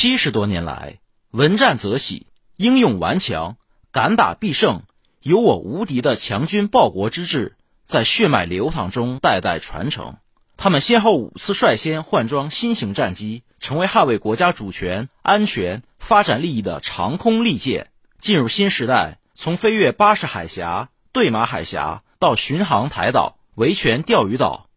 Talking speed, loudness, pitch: 235 characters per minute, -18 LUFS, 165 Hz